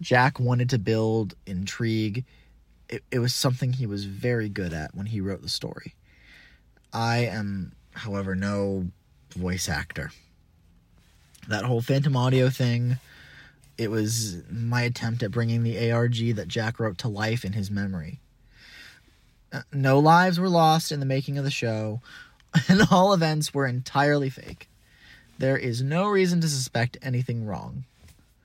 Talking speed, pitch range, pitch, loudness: 150 wpm, 100-135 Hz, 115 Hz, -25 LUFS